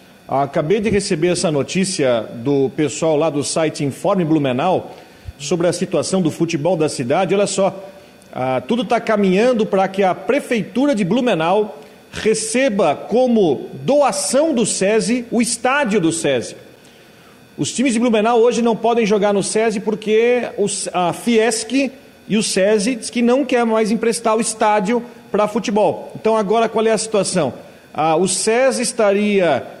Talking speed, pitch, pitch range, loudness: 155 wpm, 215 Hz, 180-235 Hz, -17 LUFS